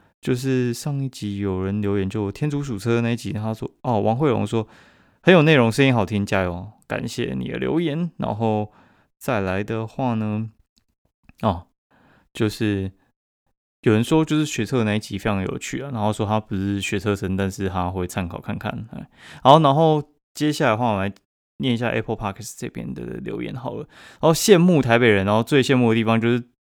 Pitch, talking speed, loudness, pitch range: 110 Hz, 295 characters per minute, -21 LUFS, 100-130 Hz